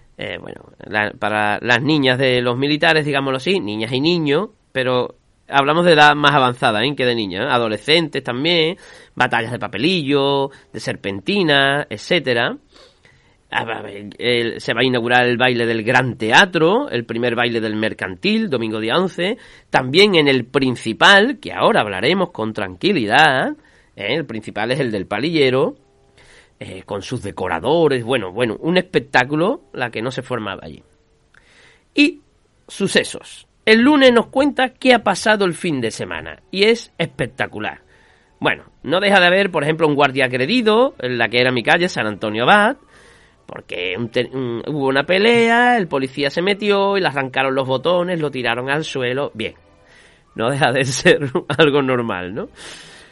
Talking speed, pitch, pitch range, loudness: 165 wpm, 135 Hz, 120-175 Hz, -17 LUFS